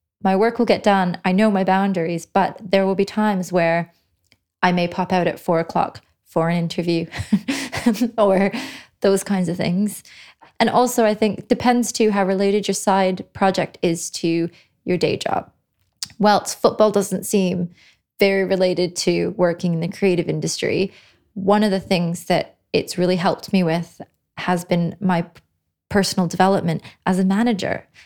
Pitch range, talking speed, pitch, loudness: 170-200 Hz, 165 wpm, 185 Hz, -20 LUFS